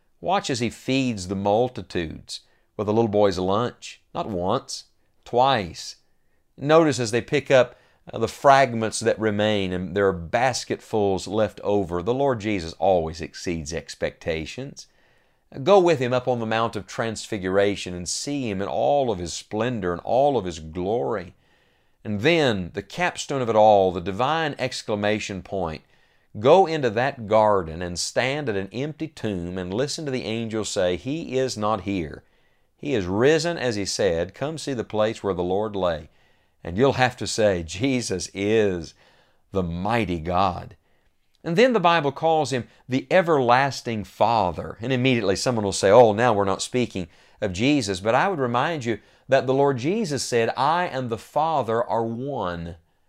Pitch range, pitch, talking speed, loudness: 95-130 Hz, 110 Hz, 170 wpm, -23 LUFS